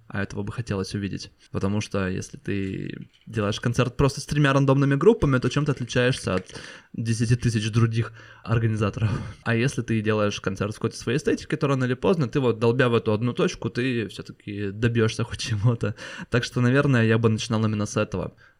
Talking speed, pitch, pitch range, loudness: 190 wpm, 115 Hz, 105-125 Hz, -24 LUFS